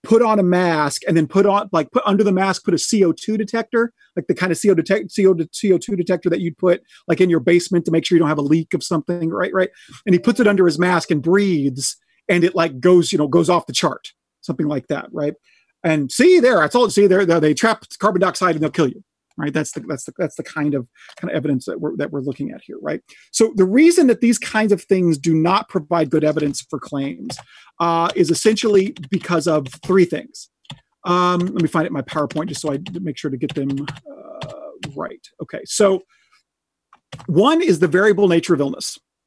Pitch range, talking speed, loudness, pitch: 155-195 Hz, 235 wpm, -18 LUFS, 175 Hz